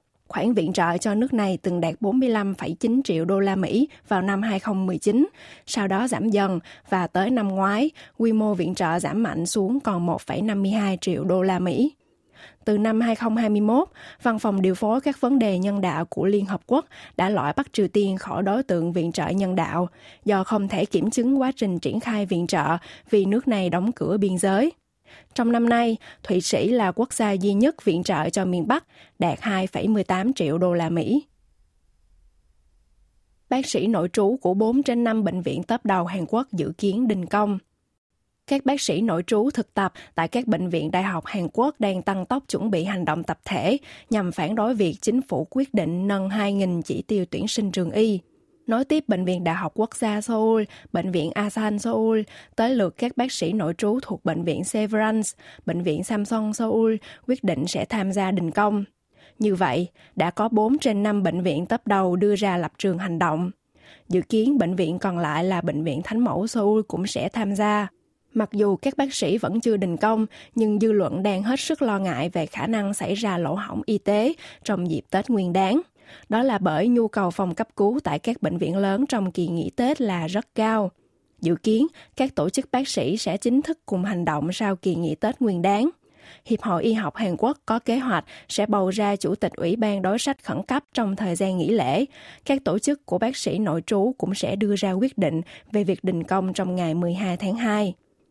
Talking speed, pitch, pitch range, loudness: 210 wpm, 205 Hz, 180-225 Hz, -23 LUFS